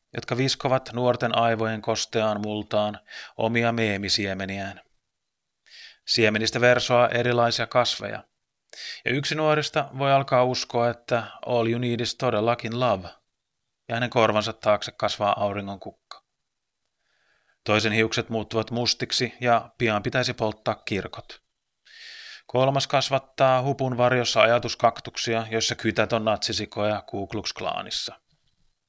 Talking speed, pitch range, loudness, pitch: 105 wpm, 110-125 Hz, -24 LUFS, 115 Hz